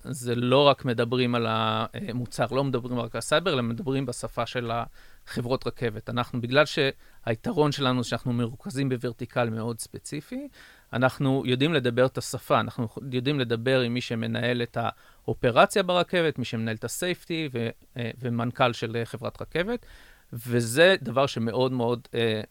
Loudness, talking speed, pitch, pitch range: -26 LUFS, 145 wpm, 125 Hz, 115-135 Hz